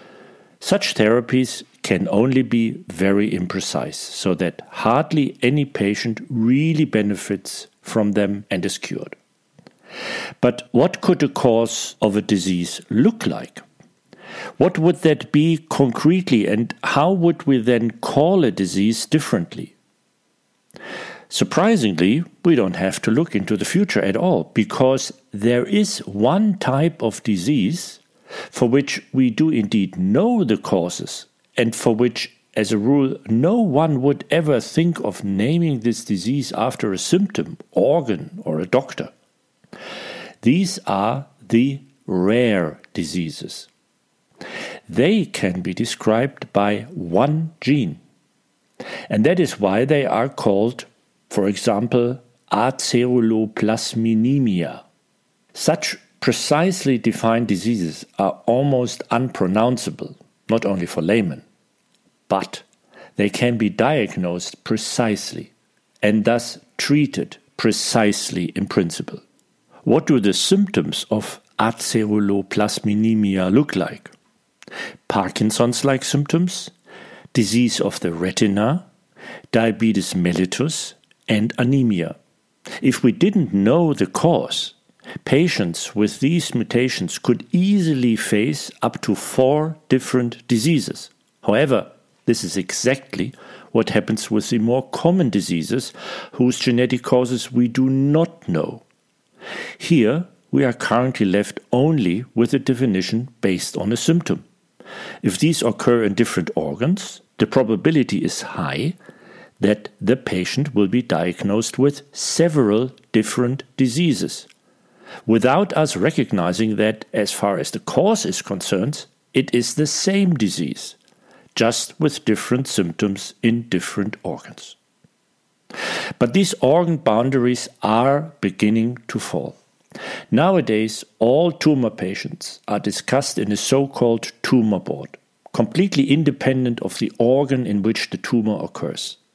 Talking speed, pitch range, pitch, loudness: 120 wpm, 110-145 Hz, 120 Hz, -19 LUFS